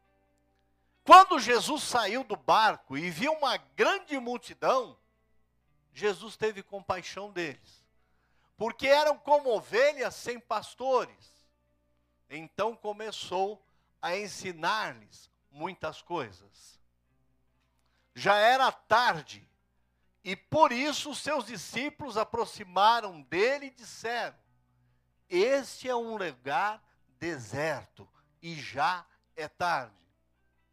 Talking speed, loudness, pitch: 90 wpm, -28 LUFS, 180 Hz